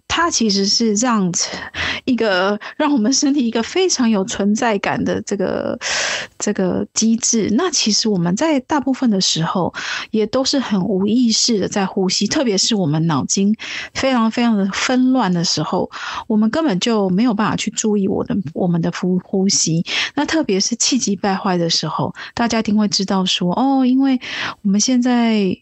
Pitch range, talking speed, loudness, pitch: 195-245 Hz, 270 characters per minute, -17 LUFS, 215 Hz